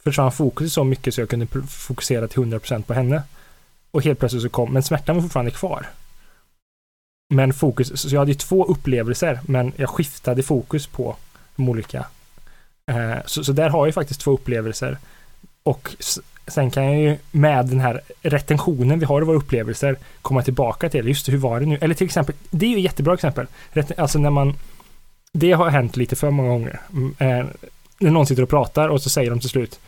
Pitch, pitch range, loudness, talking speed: 140 Hz, 125-150 Hz, -20 LUFS, 200 wpm